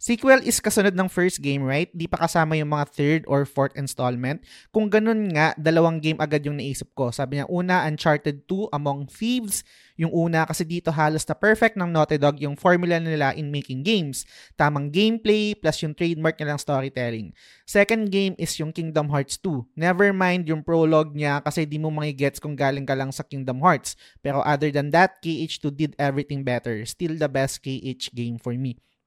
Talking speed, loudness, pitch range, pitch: 195 wpm, -23 LUFS, 140-175 Hz, 155 Hz